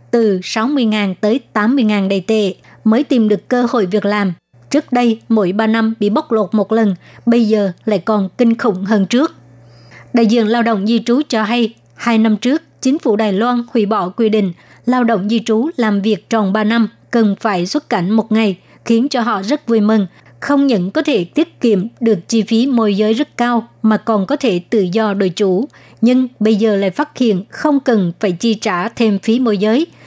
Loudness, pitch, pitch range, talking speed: -15 LUFS, 220 Hz, 205-235 Hz, 215 wpm